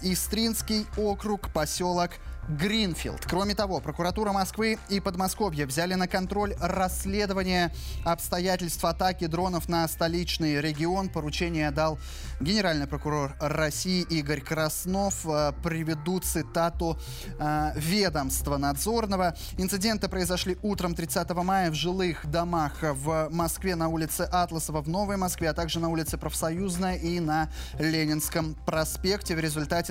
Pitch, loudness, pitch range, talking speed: 170 Hz, -28 LUFS, 155-190 Hz, 115 wpm